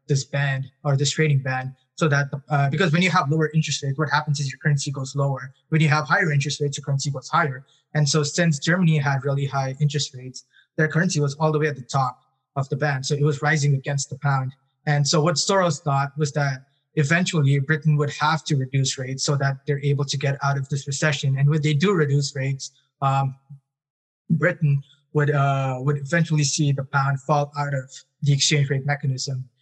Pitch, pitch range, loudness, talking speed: 145 Hz, 140-150 Hz, -22 LUFS, 220 wpm